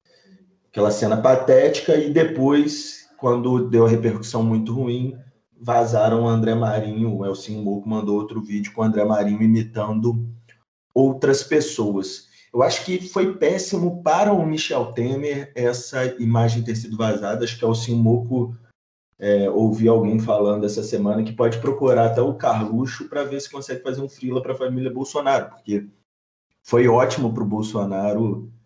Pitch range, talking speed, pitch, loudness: 110-130 Hz, 155 wpm, 115 Hz, -21 LUFS